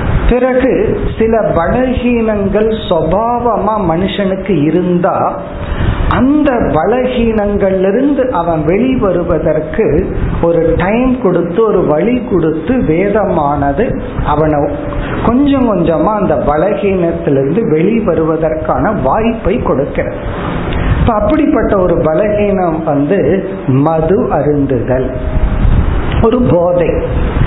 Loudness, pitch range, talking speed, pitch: -12 LUFS, 160-225 Hz, 70 wpm, 185 Hz